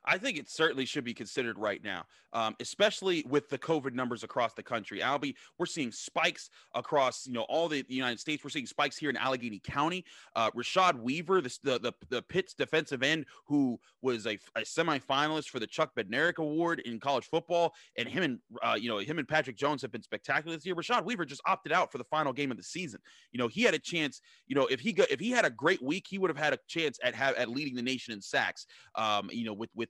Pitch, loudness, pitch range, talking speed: 145 Hz, -32 LUFS, 125-165 Hz, 245 wpm